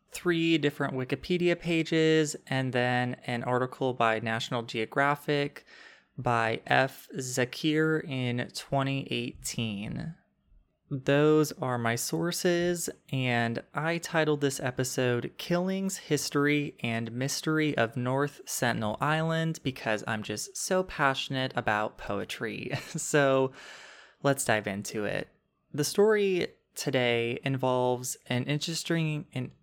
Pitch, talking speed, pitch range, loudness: 135 Hz, 105 wpm, 125-155 Hz, -29 LUFS